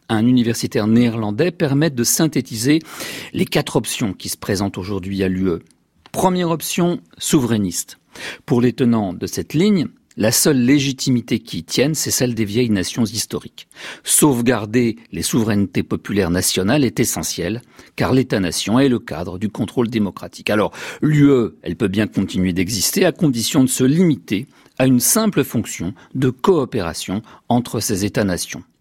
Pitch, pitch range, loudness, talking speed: 120 Hz, 100-135 Hz, -18 LUFS, 150 wpm